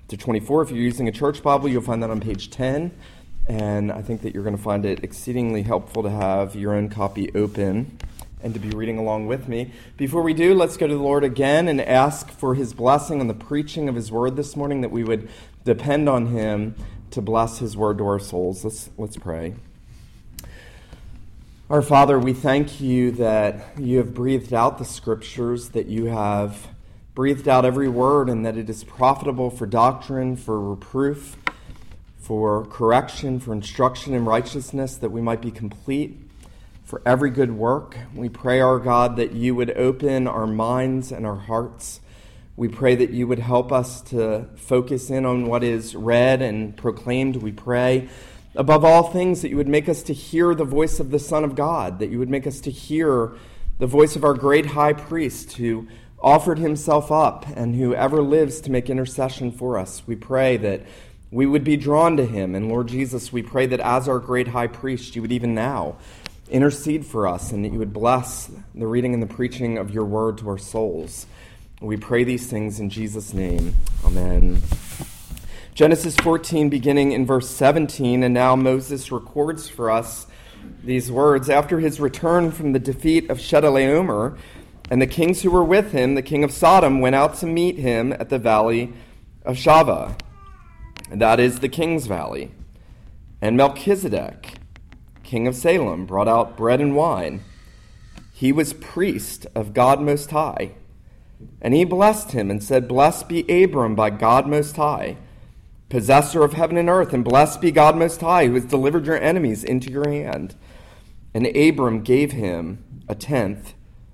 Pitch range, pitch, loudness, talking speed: 110-140 Hz, 125 Hz, -20 LUFS, 185 wpm